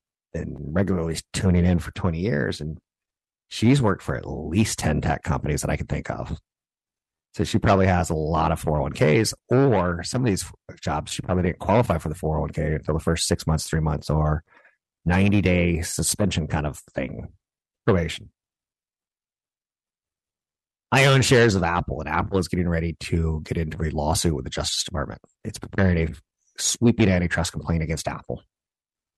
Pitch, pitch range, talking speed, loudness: 85 Hz, 80-100 Hz, 170 wpm, -23 LUFS